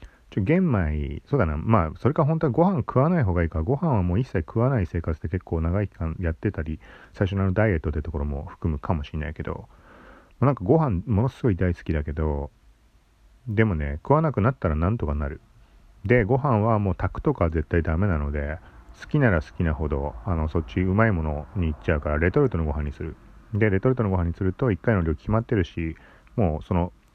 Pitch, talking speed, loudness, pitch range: 90 Hz, 430 characters per minute, -25 LUFS, 80-115 Hz